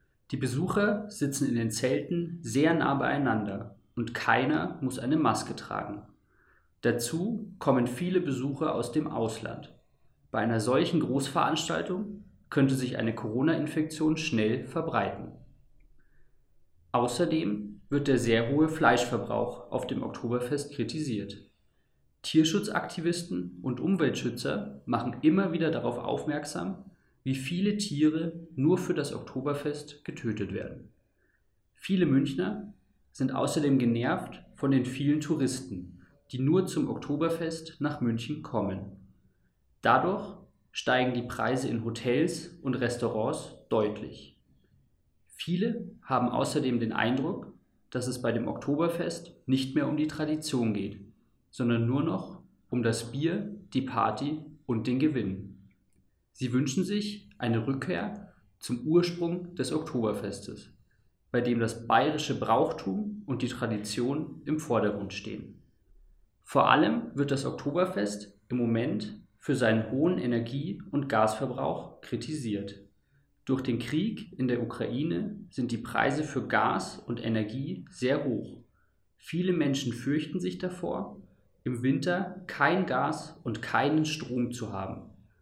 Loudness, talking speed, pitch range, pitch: -30 LUFS, 120 wpm, 115-155 Hz, 130 Hz